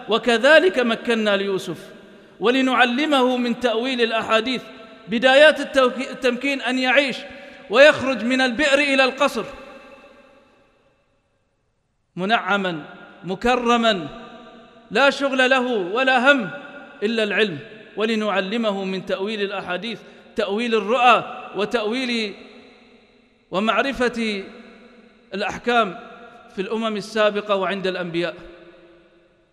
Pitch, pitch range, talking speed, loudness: 230 Hz, 200-255 Hz, 80 wpm, -19 LUFS